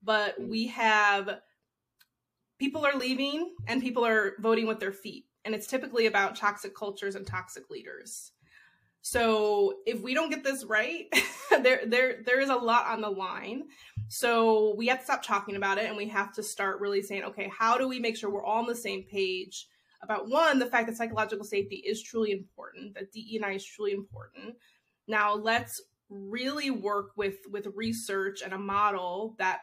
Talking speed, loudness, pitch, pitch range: 185 wpm, -29 LUFS, 215 Hz, 200-240 Hz